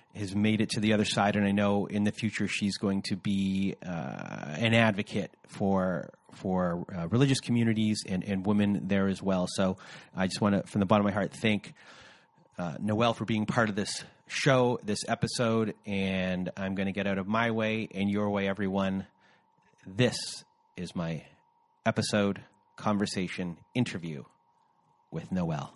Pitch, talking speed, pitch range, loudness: 105 Hz, 170 wpm, 95-110 Hz, -30 LUFS